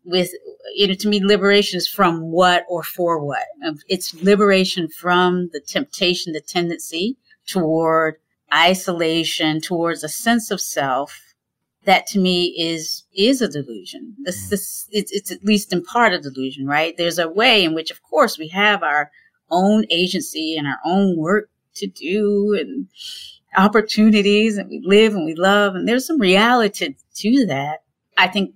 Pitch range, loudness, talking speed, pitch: 170-210 Hz, -18 LUFS, 165 wpm, 185 Hz